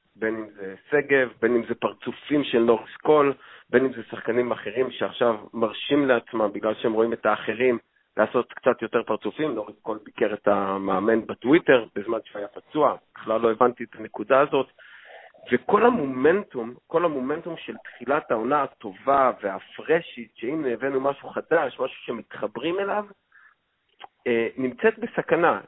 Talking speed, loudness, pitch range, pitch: 145 wpm, -24 LUFS, 115-145 Hz, 125 Hz